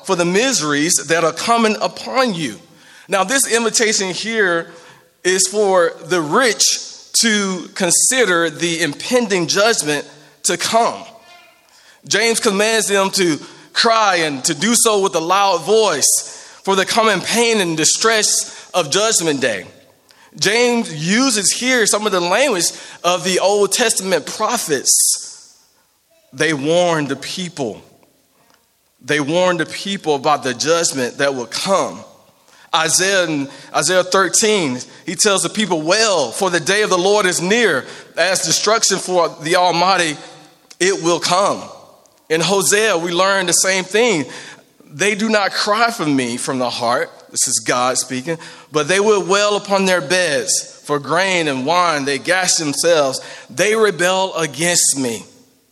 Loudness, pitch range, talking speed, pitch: -15 LUFS, 165-215 Hz, 145 wpm, 185 Hz